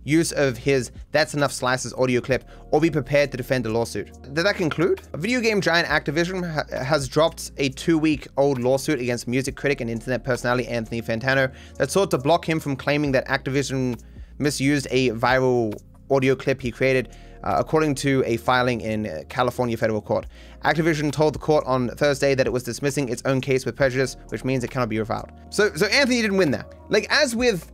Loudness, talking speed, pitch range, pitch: -22 LUFS, 200 wpm, 120-155 Hz, 135 Hz